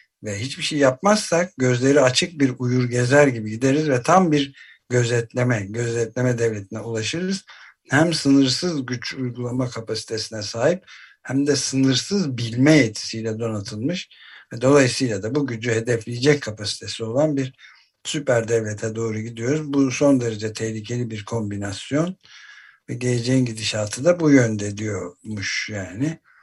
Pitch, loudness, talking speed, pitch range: 125 Hz, -21 LUFS, 125 wpm, 110-145 Hz